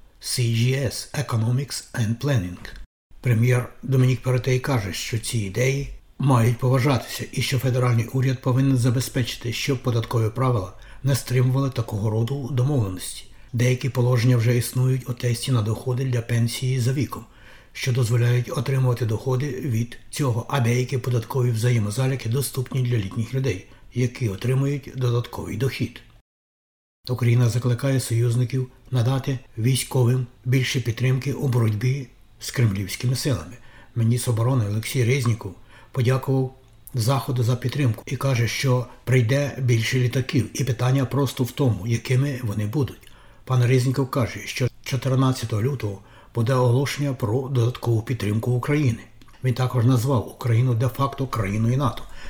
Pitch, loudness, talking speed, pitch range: 125 Hz, -23 LUFS, 125 wpm, 115-130 Hz